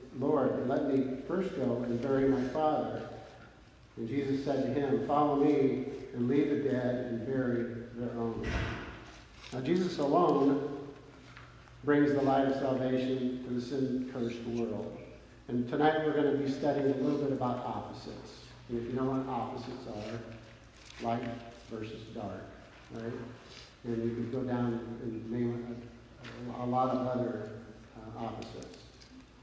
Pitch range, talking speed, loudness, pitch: 115-135 Hz, 150 wpm, -33 LUFS, 125 Hz